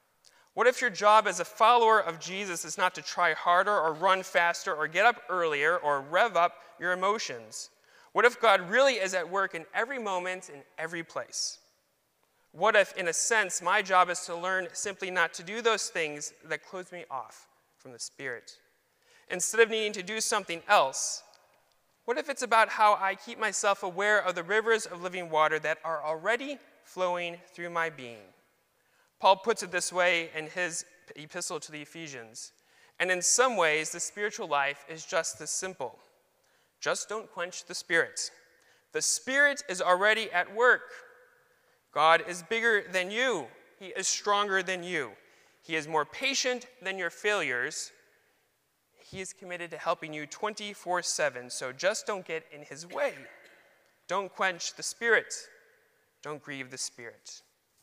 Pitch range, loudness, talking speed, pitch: 165-215 Hz, -28 LUFS, 170 wpm, 185 Hz